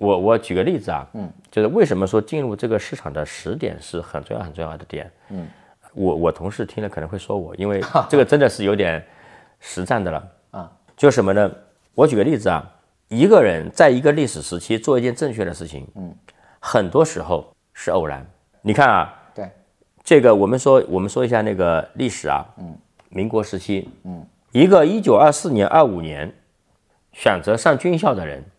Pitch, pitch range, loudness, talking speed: 100 Hz, 90-115 Hz, -18 LUFS, 275 characters per minute